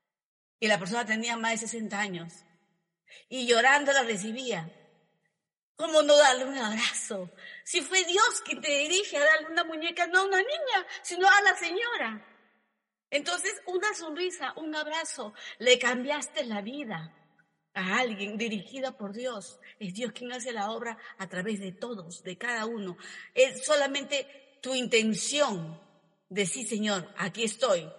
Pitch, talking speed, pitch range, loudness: 240 Hz, 155 wpm, 205-300 Hz, -28 LUFS